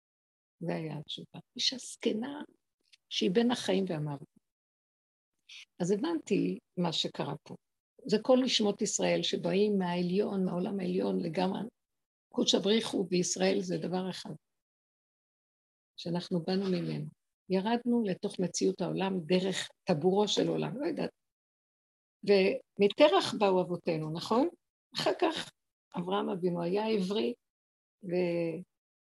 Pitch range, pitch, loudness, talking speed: 175-215 Hz, 190 Hz, -31 LUFS, 110 wpm